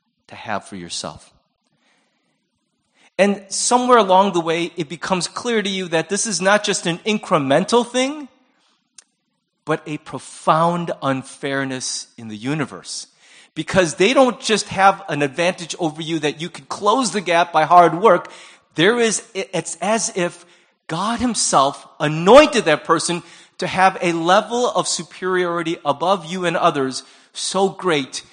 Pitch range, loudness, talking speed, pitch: 160-200 Hz, -18 LUFS, 145 wpm, 175 Hz